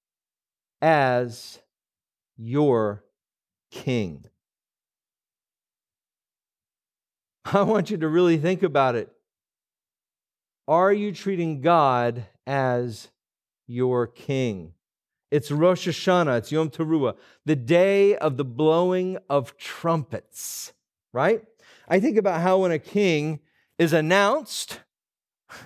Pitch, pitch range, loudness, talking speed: 155 Hz, 125-185 Hz, -23 LUFS, 95 wpm